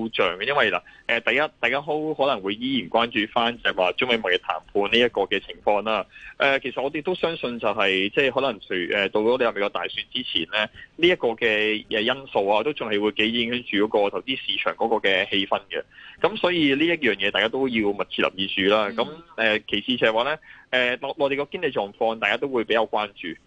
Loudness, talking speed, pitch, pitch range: -23 LUFS, 345 characters per minute, 120 Hz, 105-140 Hz